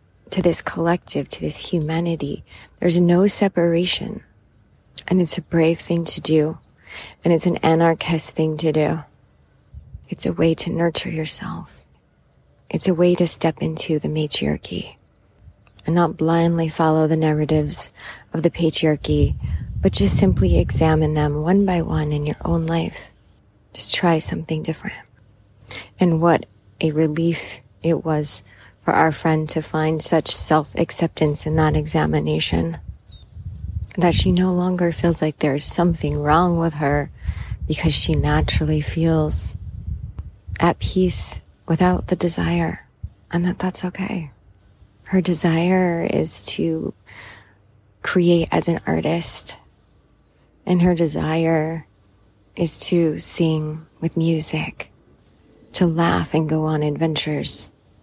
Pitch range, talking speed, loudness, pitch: 105-170 Hz, 130 wpm, -19 LUFS, 155 Hz